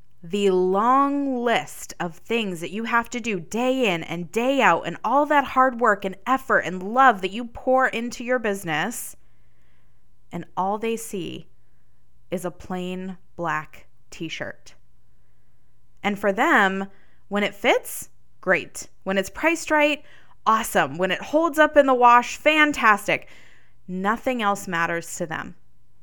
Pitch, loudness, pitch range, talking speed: 205 Hz, -22 LUFS, 180-255 Hz, 150 wpm